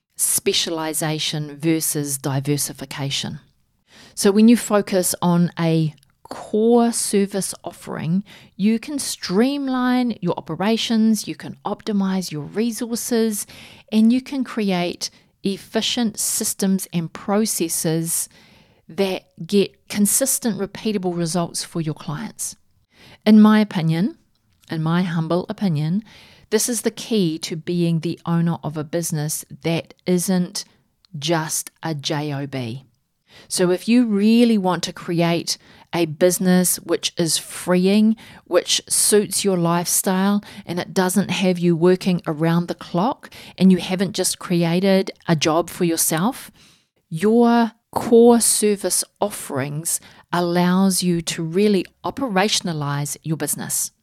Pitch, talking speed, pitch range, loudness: 180 Hz, 120 wpm, 165-210 Hz, -20 LUFS